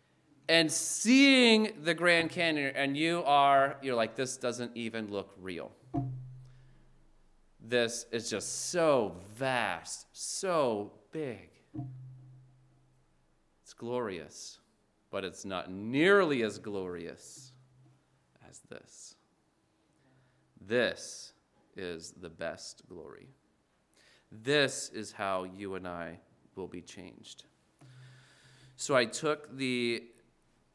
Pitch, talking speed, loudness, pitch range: 130 Hz, 100 wpm, -30 LUFS, 105-140 Hz